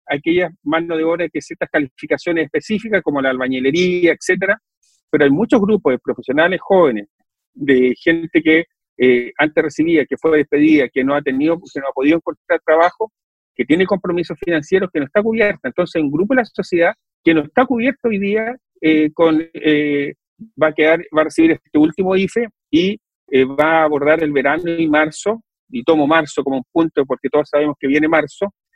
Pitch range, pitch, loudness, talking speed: 150-190 Hz, 160 Hz, -16 LUFS, 190 wpm